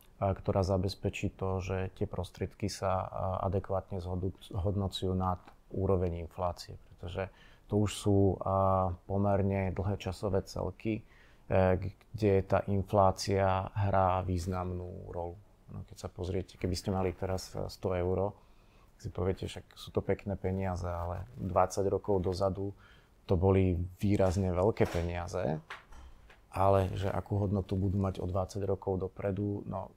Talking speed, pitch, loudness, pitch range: 130 wpm, 95 Hz, -33 LUFS, 95-100 Hz